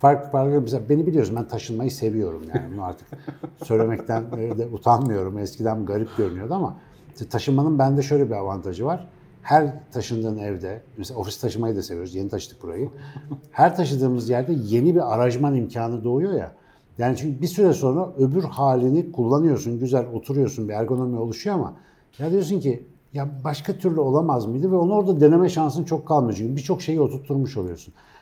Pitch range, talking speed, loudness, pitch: 115-150 Hz, 165 wpm, -23 LUFS, 135 Hz